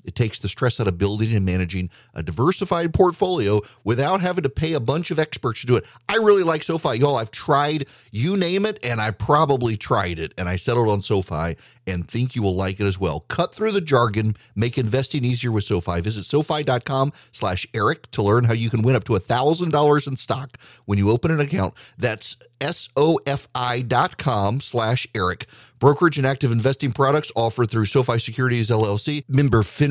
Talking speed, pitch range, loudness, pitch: 195 wpm, 110-145 Hz, -21 LUFS, 125 Hz